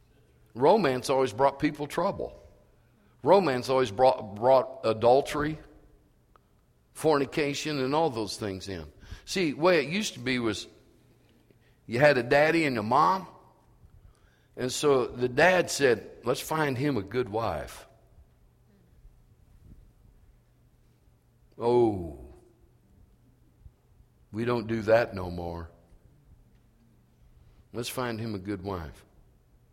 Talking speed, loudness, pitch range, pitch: 110 wpm, -27 LUFS, 105-135 Hz, 120 Hz